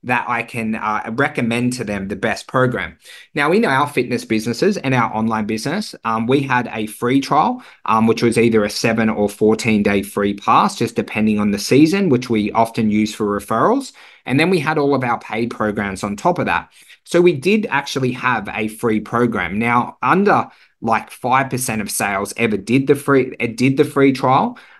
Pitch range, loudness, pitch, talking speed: 110-130 Hz, -17 LUFS, 115 Hz, 195 wpm